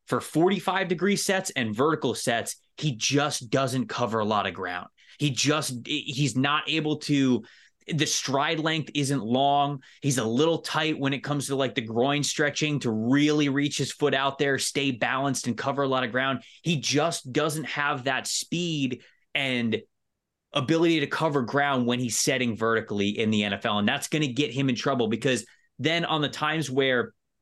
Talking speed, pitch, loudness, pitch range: 185 wpm, 140 Hz, -26 LUFS, 125-150 Hz